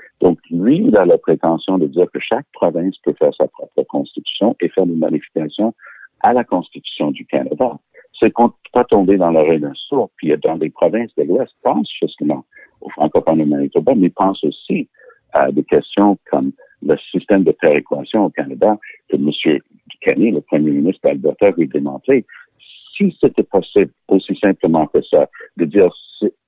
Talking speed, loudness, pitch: 175 wpm, -16 LUFS, 370 Hz